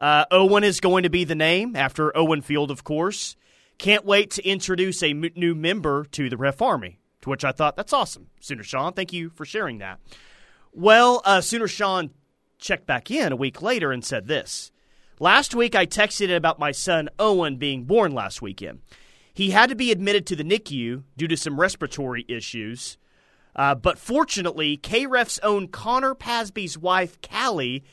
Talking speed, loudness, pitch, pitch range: 185 wpm, -22 LUFS, 175 Hz, 145-205 Hz